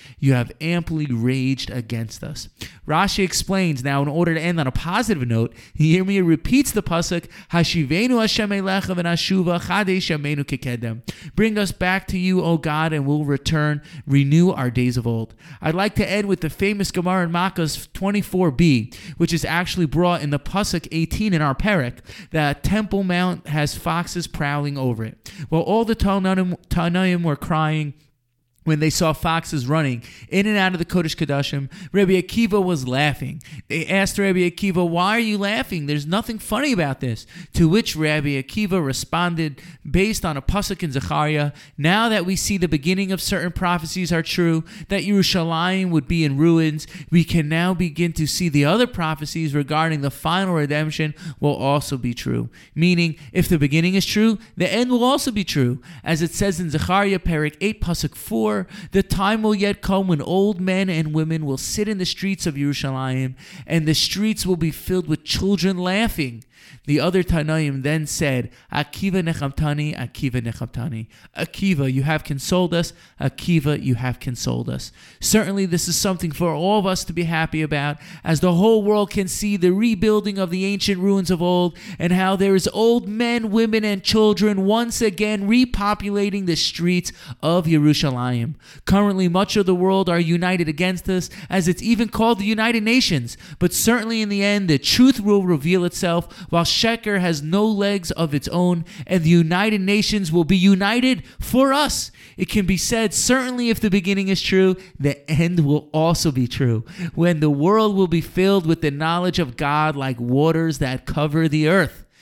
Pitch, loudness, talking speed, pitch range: 170 Hz, -20 LUFS, 175 wpm, 150-195 Hz